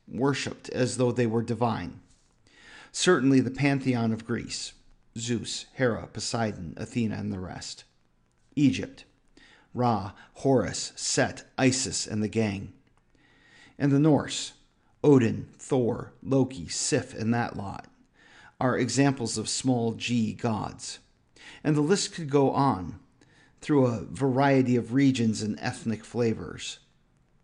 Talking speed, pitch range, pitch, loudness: 120 wpm, 110-135 Hz, 120 Hz, -27 LUFS